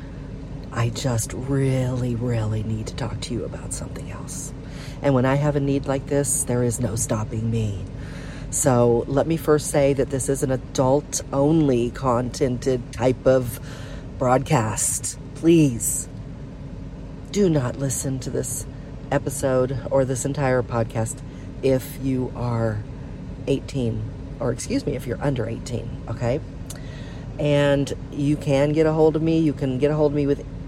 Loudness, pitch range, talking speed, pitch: -23 LUFS, 120-140 Hz, 155 wpm, 135 Hz